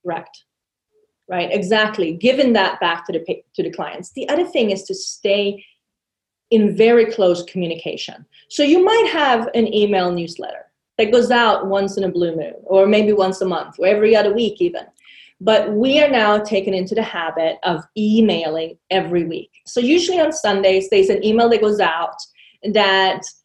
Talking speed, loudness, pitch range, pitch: 180 wpm, -17 LUFS, 190-240 Hz, 210 Hz